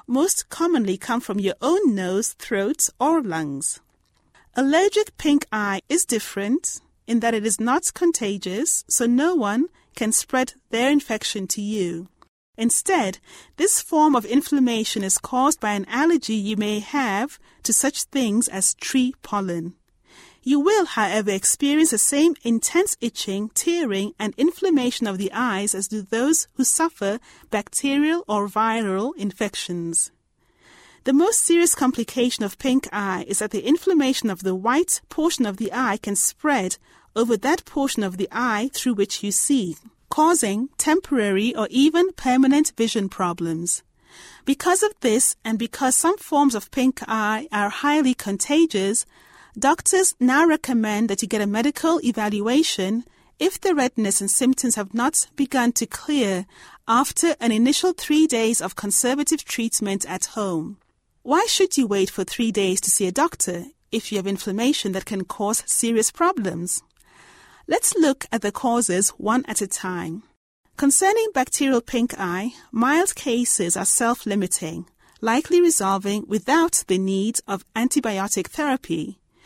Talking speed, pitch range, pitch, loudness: 150 wpm, 205-290 Hz, 235 Hz, -21 LUFS